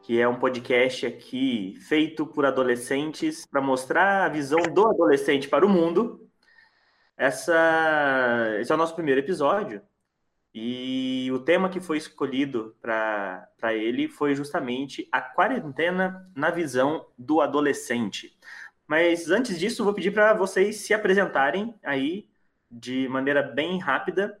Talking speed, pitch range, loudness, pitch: 135 wpm, 130-185 Hz, -24 LUFS, 155 Hz